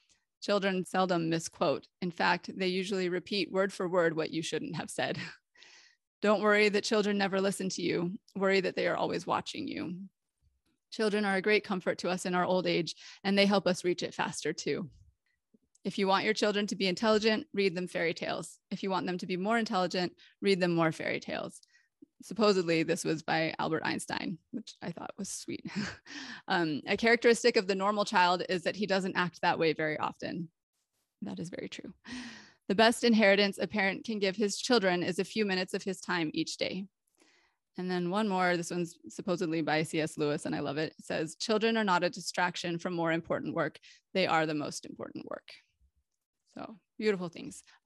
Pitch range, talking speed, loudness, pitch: 175-210 Hz, 200 wpm, -31 LUFS, 190 Hz